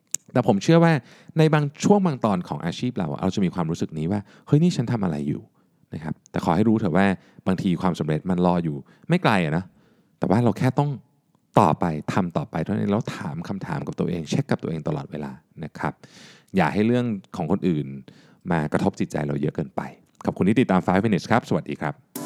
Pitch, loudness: 115 Hz, -23 LUFS